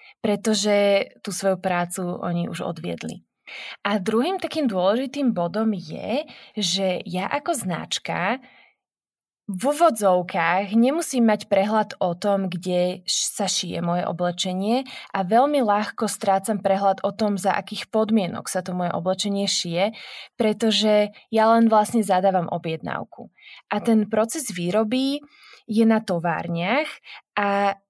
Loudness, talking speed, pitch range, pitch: -23 LUFS, 125 wpm, 190-225 Hz, 205 Hz